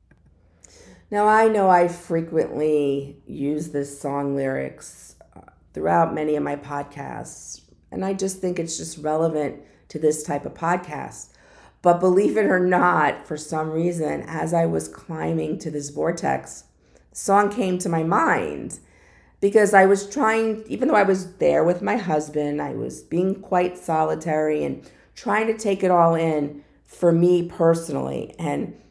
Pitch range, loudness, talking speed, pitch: 150-185 Hz, -22 LUFS, 155 wpm, 165 Hz